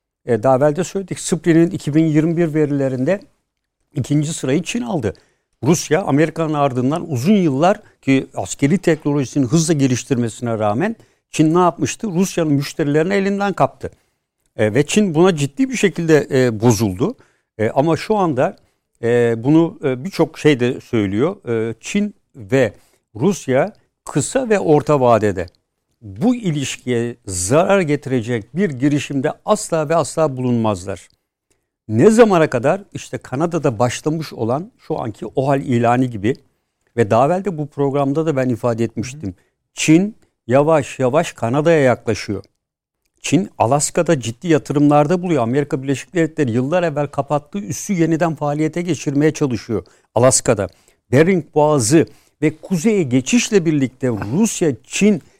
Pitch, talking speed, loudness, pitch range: 145 Hz, 120 wpm, -17 LUFS, 125-165 Hz